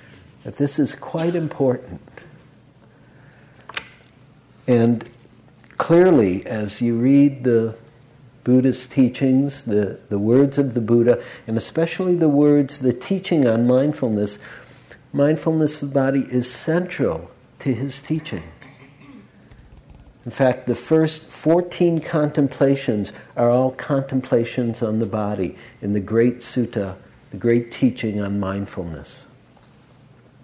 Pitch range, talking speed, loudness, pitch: 115-145 Hz, 110 wpm, -20 LUFS, 125 Hz